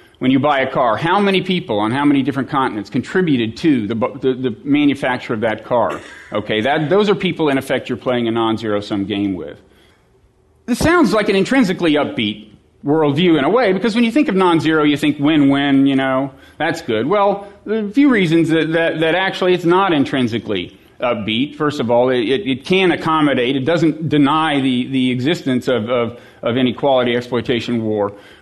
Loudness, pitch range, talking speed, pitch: -16 LUFS, 125-180 Hz, 200 wpm, 140 Hz